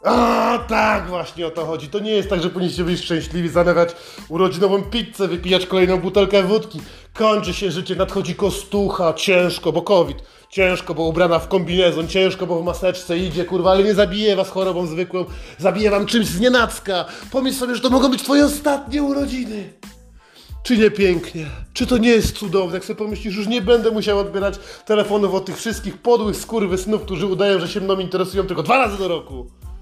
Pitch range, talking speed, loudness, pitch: 180-215 Hz, 185 wpm, -19 LUFS, 195 Hz